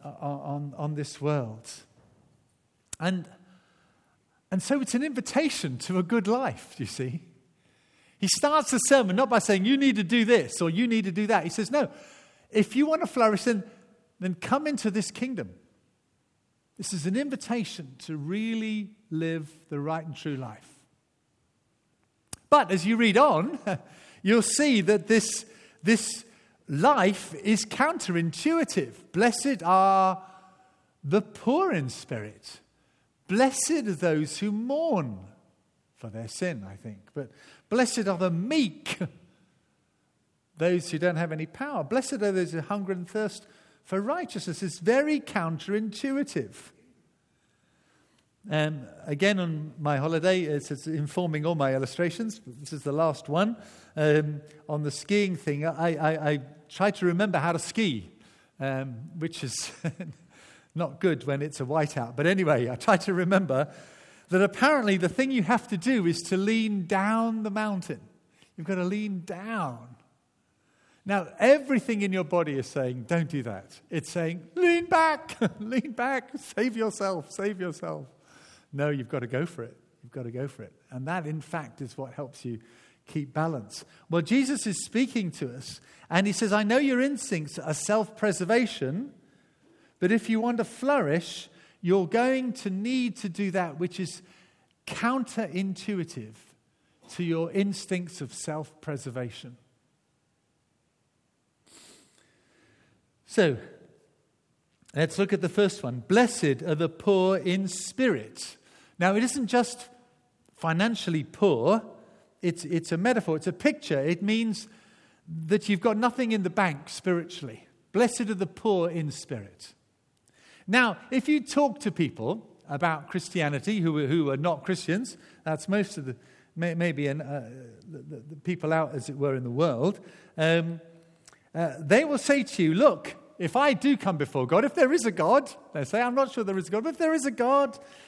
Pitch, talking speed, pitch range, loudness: 185 Hz, 160 wpm, 155-220 Hz, -27 LUFS